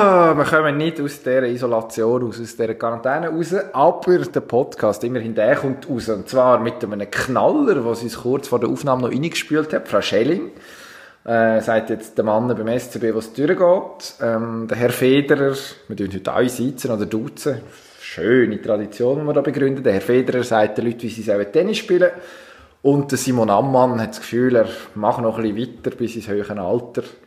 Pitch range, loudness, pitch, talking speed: 115-140 Hz, -19 LUFS, 120 Hz, 195 wpm